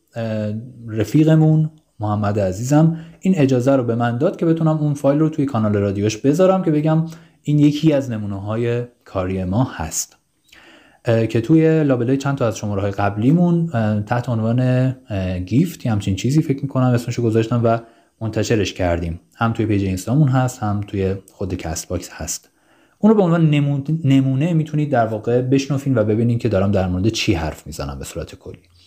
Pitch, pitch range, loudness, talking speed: 120 Hz, 105-145 Hz, -18 LUFS, 175 wpm